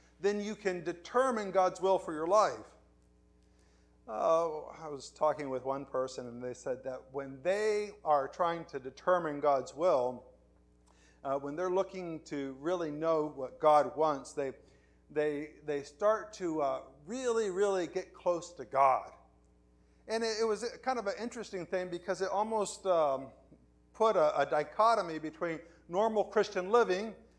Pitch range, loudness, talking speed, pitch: 135-195 Hz, -33 LUFS, 155 wpm, 160 Hz